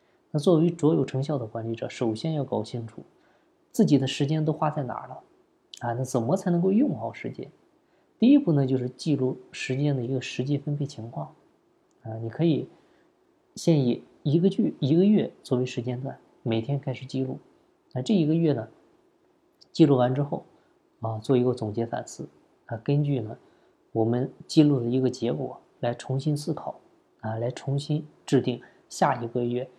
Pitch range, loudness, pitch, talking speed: 125-160 Hz, -26 LUFS, 140 Hz, 260 characters per minute